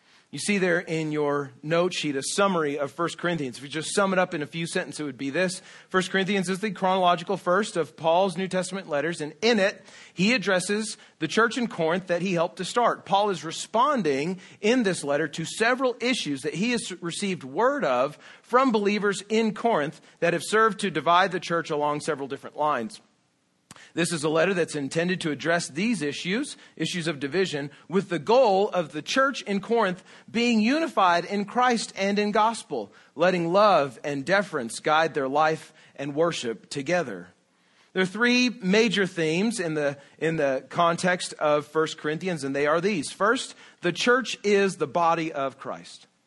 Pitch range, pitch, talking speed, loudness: 155-205 Hz, 180 Hz, 185 wpm, -25 LUFS